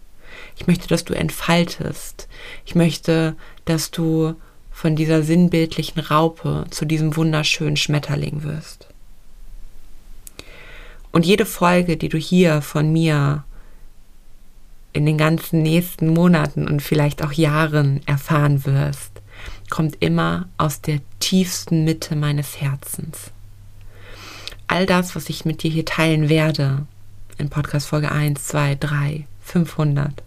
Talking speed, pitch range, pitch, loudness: 120 wpm, 145-165 Hz, 155 Hz, -19 LUFS